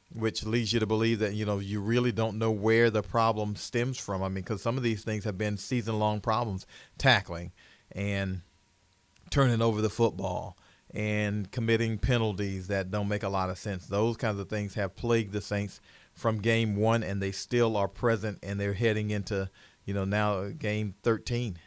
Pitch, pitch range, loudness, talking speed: 105 Hz, 100-115 Hz, -30 LUFS, 195 wpm